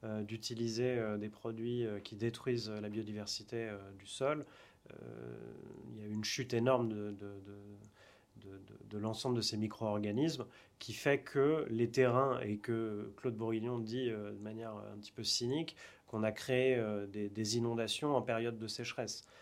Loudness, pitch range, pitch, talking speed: -37 LUFS, 105-120 Hz, 110 Hz, 155 wpm